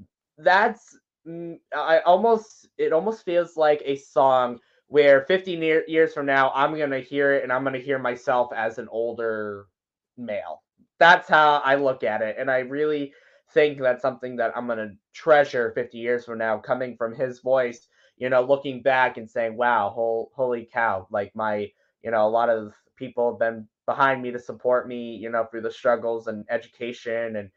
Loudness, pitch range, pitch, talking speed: -23 LUFS, 115-140 Hz, 125 Hz, 190 wpm